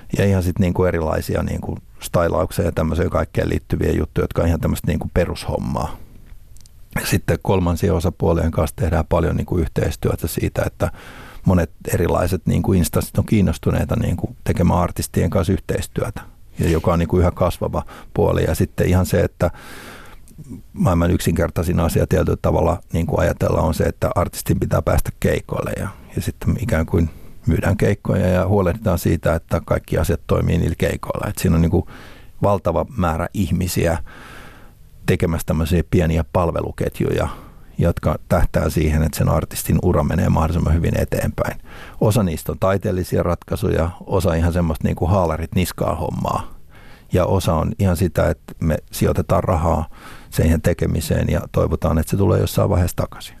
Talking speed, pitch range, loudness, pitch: 150 wpm, 85-95 Hz, -20 LUFS, 90 Hz